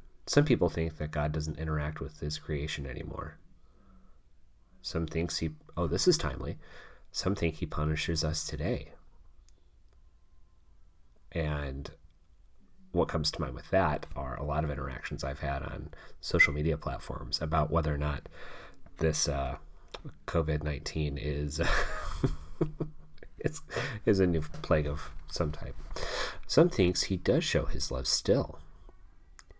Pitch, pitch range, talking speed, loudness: 80 Hz, 75-85 Hz, 135 wpm, -32 LUFS